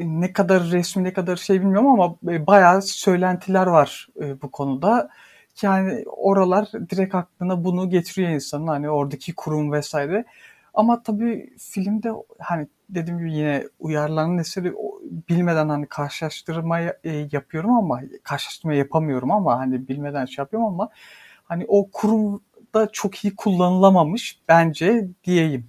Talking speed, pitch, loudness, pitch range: 125 wpm, 180 Hz, -21 LUFS, 155-200 Hz